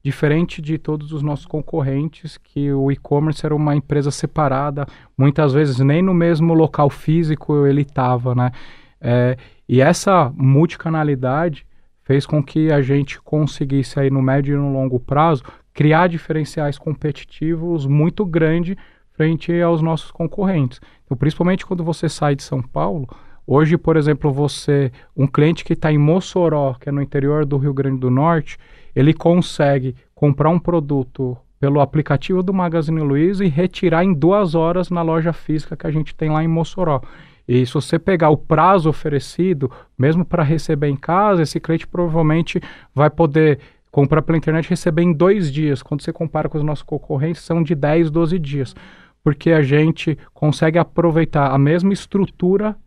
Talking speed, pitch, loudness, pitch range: 165 wpm, 155 Hz, -18 LUFS, 140-165 Hz